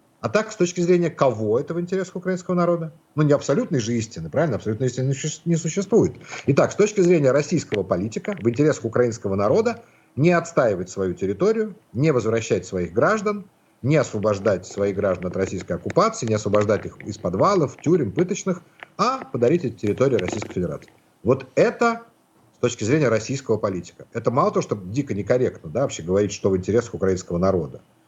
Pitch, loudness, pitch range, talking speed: 135 Hz, -22 LUFS, 105-175 Hz, 170 wpm